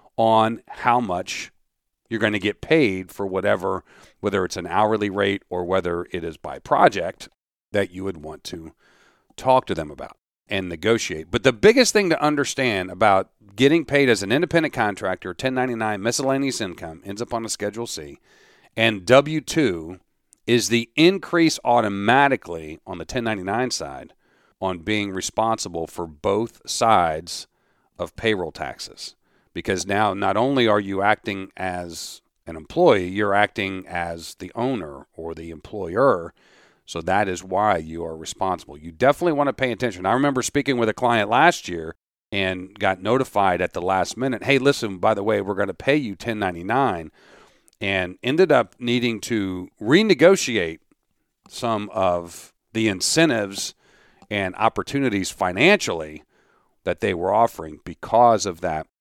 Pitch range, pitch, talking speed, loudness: 95-125 Hz, 105 Hz, 155 wpm, -21 LUFS